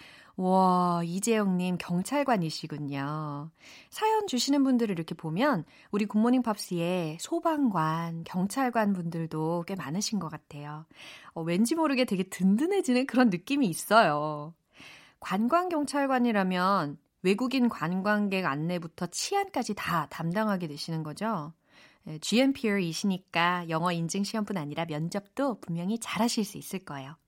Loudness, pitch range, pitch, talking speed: -29 LUFS, 165-230 Hz, 185 Hz, 300 characters per minute